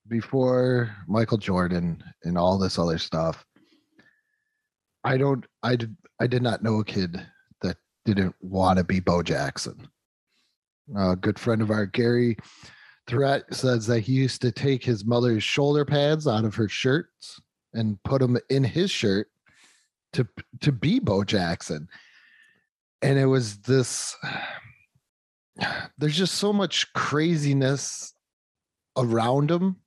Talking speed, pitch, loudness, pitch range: 135 wpm, 125 Hz, -25 LUFS, 105-140 Hz